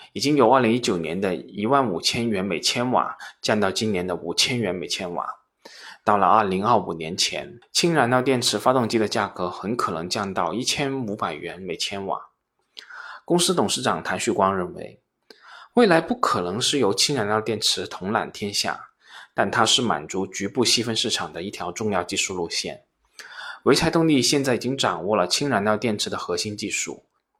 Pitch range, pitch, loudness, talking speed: 105-145 Hz, 120 Hz, -22 LUFS, 280 characters per minute